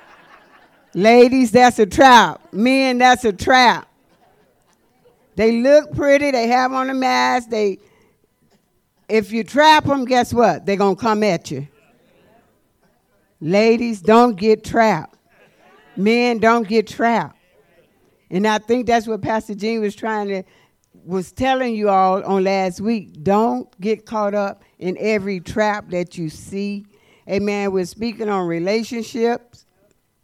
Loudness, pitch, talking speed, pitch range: -17 LUFS, 220 Hz, 135 wpm, 200-240 Hz